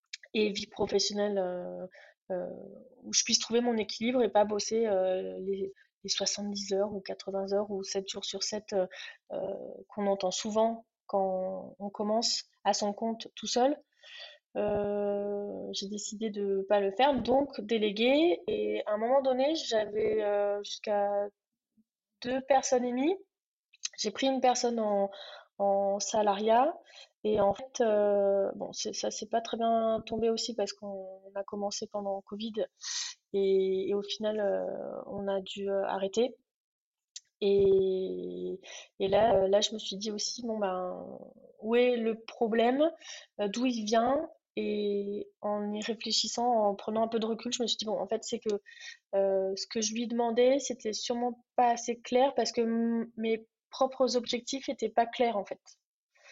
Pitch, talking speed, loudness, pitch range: 215 Hz, 165 wpm, -31 LUFS, 200-240 Hz